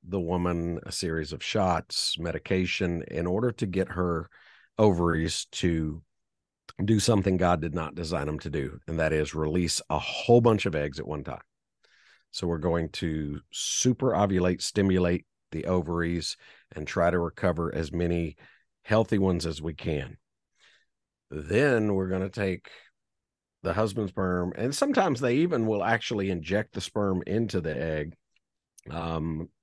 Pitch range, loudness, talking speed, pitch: 80-100 Hz, -28 LUFS, 155 wpm, 90 Hz